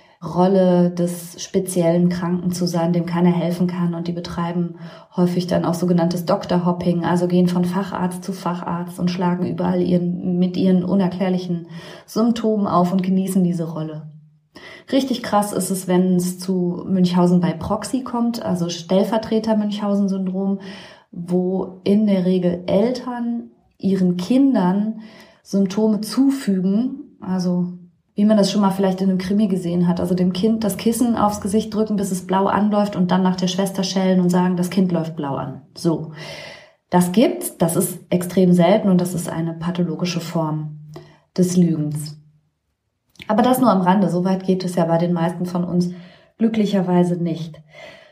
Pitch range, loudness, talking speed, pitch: 175-200 Hz, -19 LUFS, 160 wpm, 180 Hz